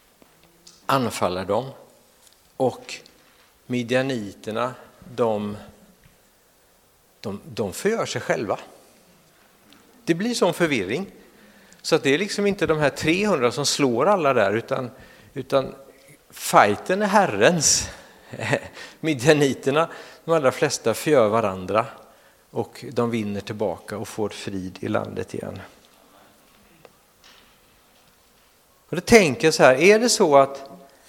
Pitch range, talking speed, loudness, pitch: 115-165 Hz, 110 wpm, -21 LUFS, 135 Hz